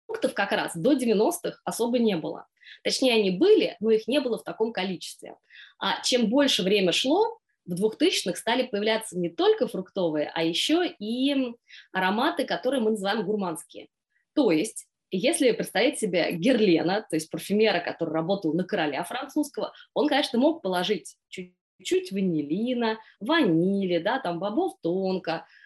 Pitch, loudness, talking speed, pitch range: 215 Hz, -25 LUFS, 145 wpm, 180-265 Hz